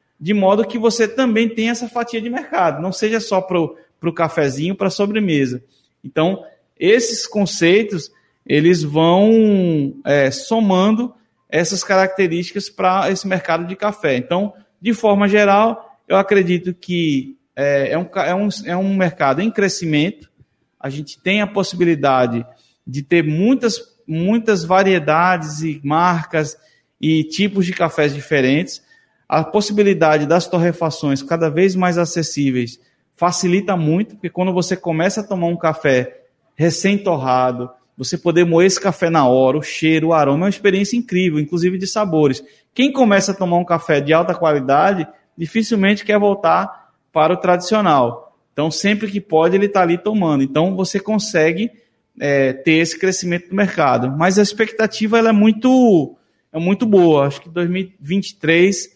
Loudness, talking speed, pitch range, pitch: -16 LUFS, 150 wpm, 160-205 Hz, 180 Hz